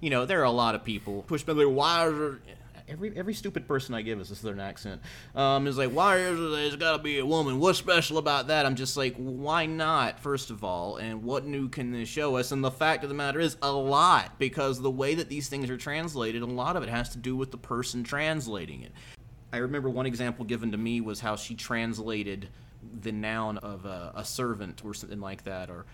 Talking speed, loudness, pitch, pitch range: 240 wpm, -29 LUFS, 130 Hz, 115-145 Hz